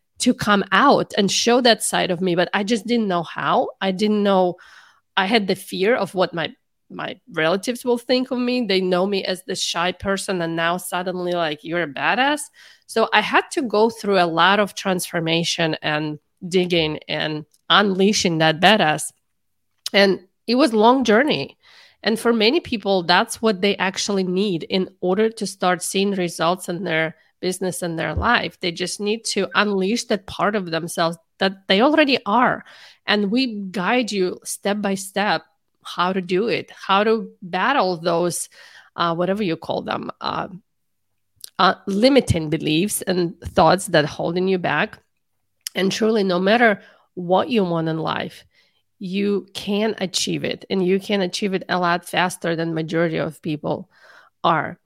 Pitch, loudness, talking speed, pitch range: 190 Hz, -20 LUFS, 170 wpm, 175-210 Hz